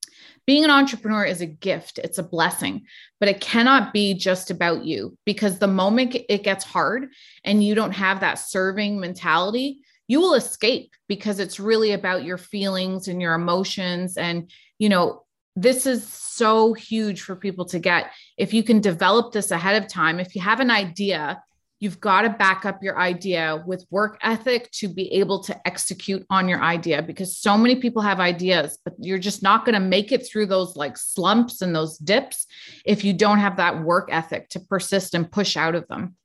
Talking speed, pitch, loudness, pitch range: 195 wpm, 195 Hz, -21 LUFS, 180-215 Hz